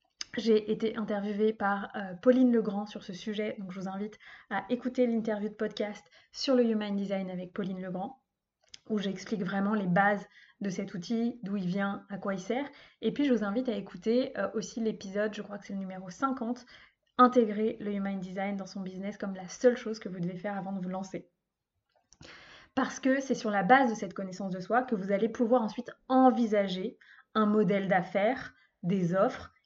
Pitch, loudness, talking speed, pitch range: 210 Hz, -31 LUFS, 200 wpm, 195-235 Hz